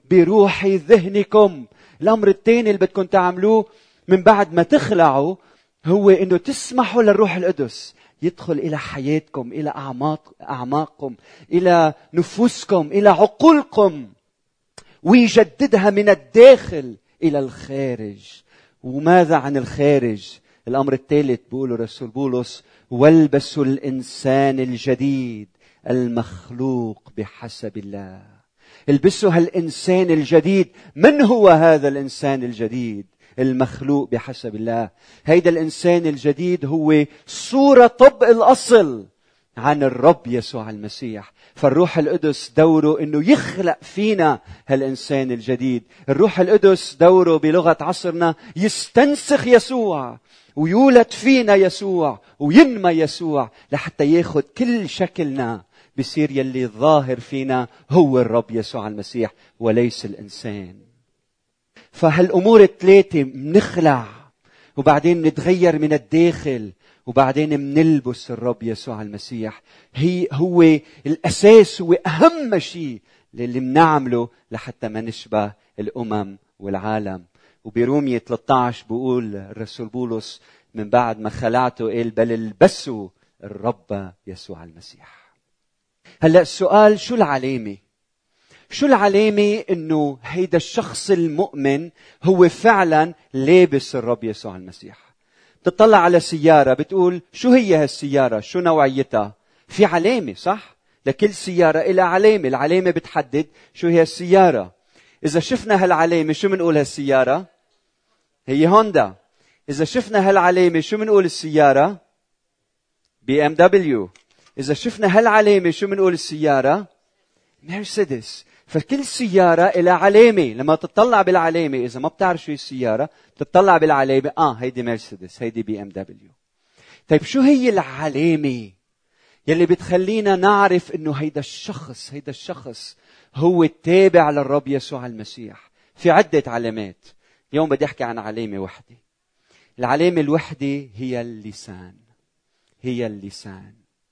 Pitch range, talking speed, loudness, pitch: 125-180 Hz, 105 wpm, -17 LUFS, 150 Hz